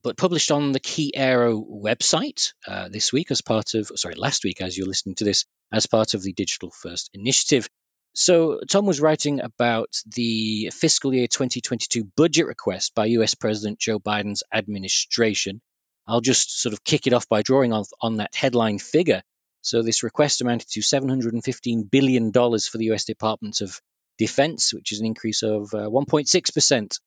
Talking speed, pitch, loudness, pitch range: 175 wpm, 115 Hz, -22 LUFS, 110-135 Hz